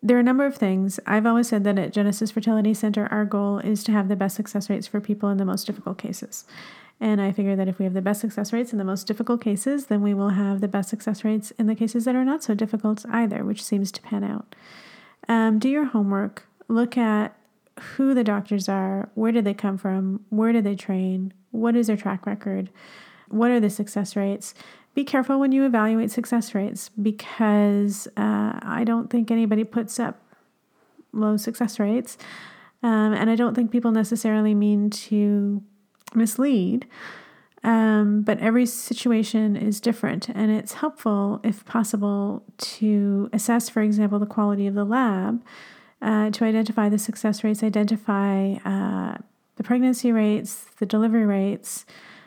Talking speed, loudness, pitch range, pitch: 185 wpm, -23 LUFS, 205-230 Hz, 215 Hz